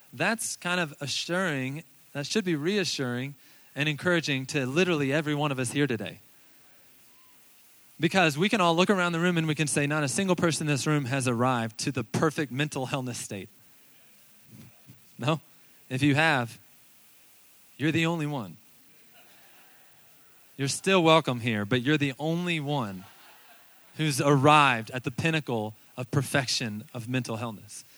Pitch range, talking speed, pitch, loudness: 130-160 Hz, 155 wpm, 145 Hz, -27 LUFS